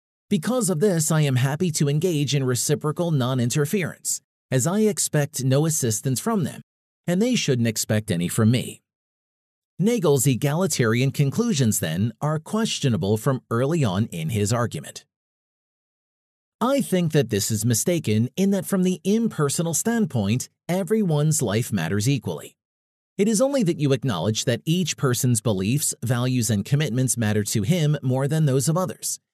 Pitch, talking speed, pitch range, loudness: 140 Hz, 155 wpm, 120-175 Hz, -22 LUFS